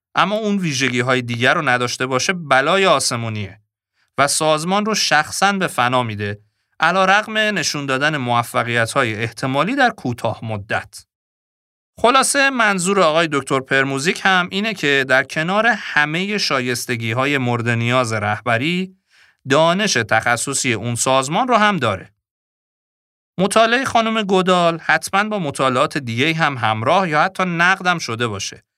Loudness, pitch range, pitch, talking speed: -17 LUFS, 120-190 Hz, 140 Hz, 135 wpm